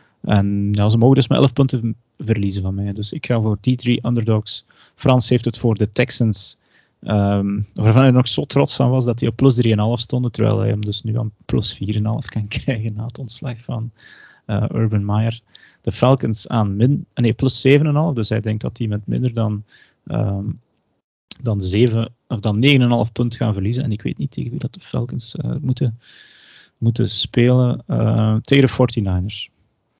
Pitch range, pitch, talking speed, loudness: 105-125 Hz, 115 Hz, 190 wpm, -18 LUFS